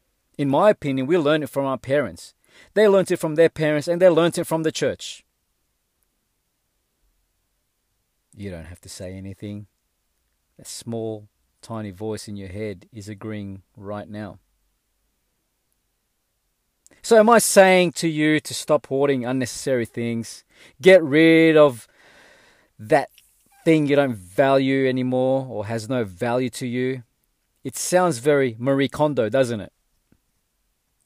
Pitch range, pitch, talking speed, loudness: 100-150 Hz, 125 Hz, 140 wpm, -20 LUFS